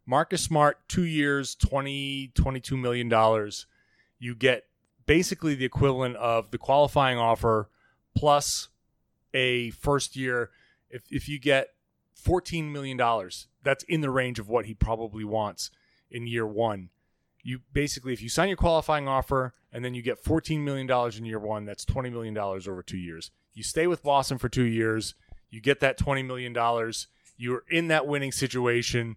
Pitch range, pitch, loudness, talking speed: 115-140 Hz, 125 Hz, -27 LUFS, 170 wpm